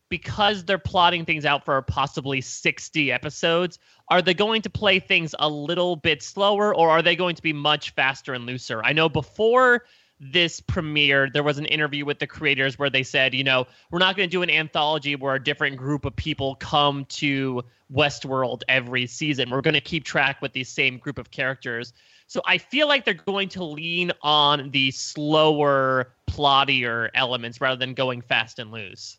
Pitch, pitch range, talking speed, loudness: 145 Hz, 130-170 Hz, 195 wpm, -22 LUFS